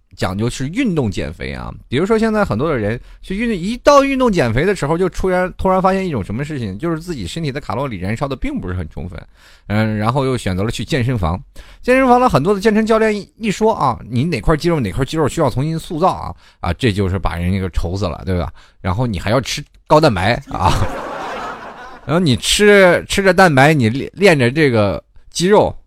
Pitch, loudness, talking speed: 140 Hz, -16 LUFS, 330 characters per minute